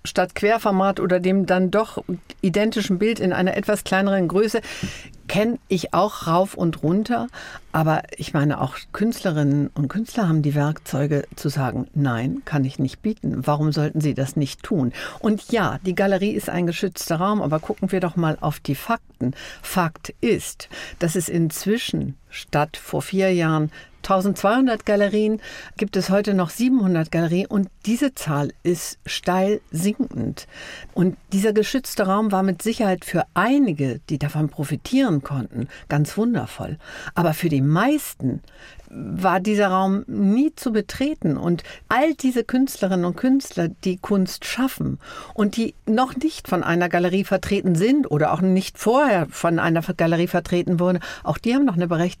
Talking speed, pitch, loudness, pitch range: 160 wpm, 185 Hz, -22 LUFS, 155-215 Hz